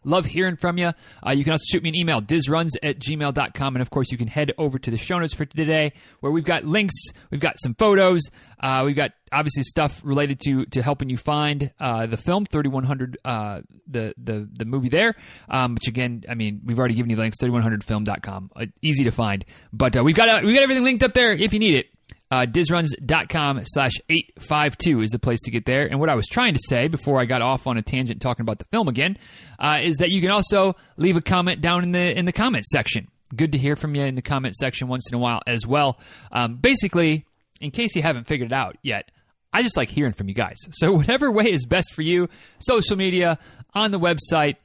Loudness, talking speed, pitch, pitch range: -21 LUFS, 240 wpm, 145 Hz, 125-170 Hz